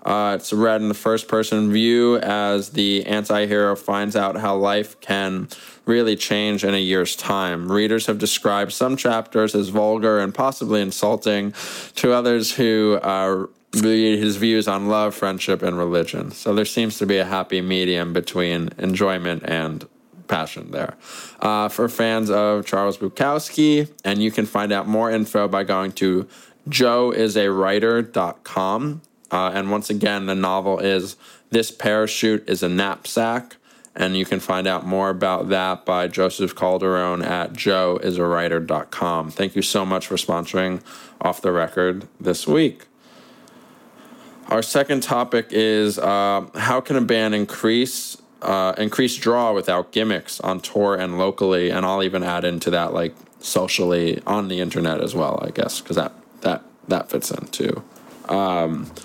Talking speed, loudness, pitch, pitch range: 155 wpm, -21 LUFS, 100 Hz, 95-110 Hz